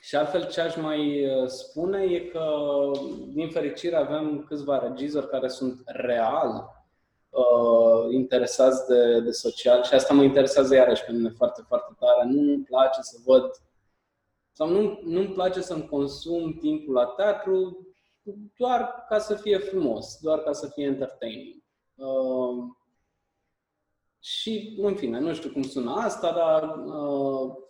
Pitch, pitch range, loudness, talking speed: 150 Hz, 130-195 Hz, -24 LUFS, 140 wpm